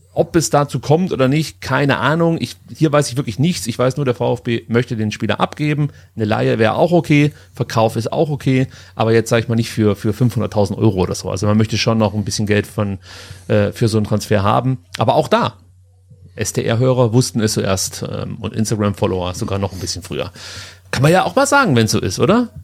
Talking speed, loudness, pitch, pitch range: 225 wpm, -17 LUFS, 115 Hz, 105-130 Hz